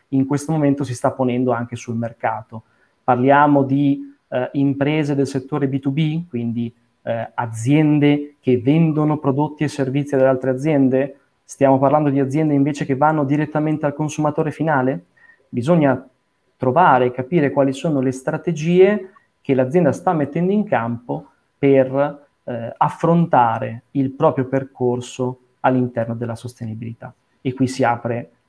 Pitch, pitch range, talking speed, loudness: 140 Hz, 125-150 Hz, 135 wpm, -19 LUFS